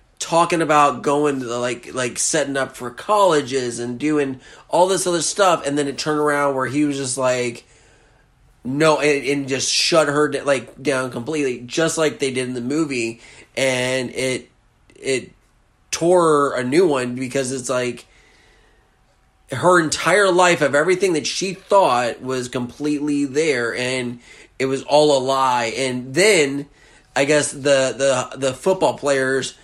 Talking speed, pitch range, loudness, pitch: 160 wpm, 125-150 Hz, -19 LUFS, 140 Hz